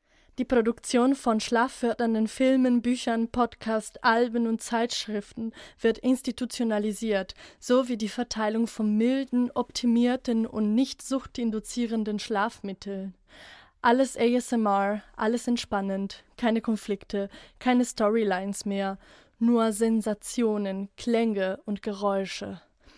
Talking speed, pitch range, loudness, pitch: 95 wpm, 210-245 Hz, -27 LUFS, 230 Hz